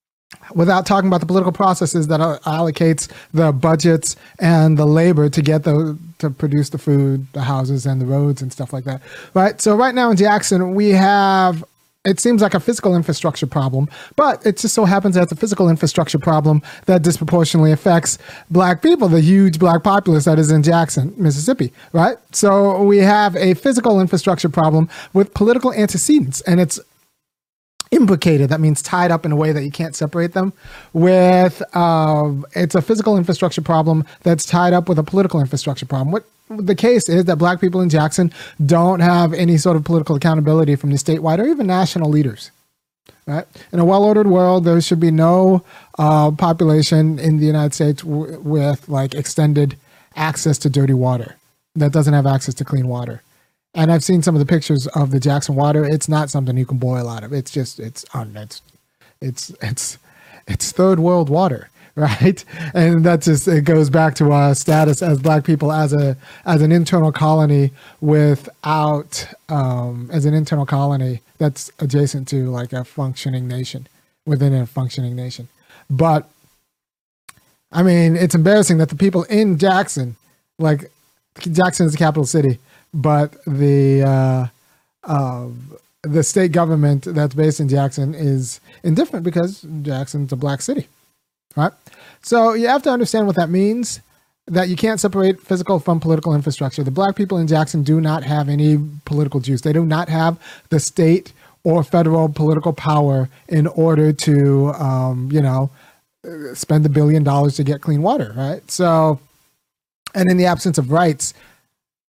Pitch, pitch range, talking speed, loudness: 155 Hz, 145-180 Hz, 170 wpm, -16 LUFS